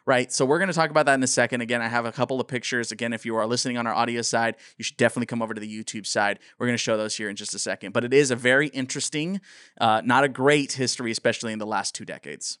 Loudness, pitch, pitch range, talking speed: -24 LUFS, 120 Hz, 115-135 Hz, 290 wpm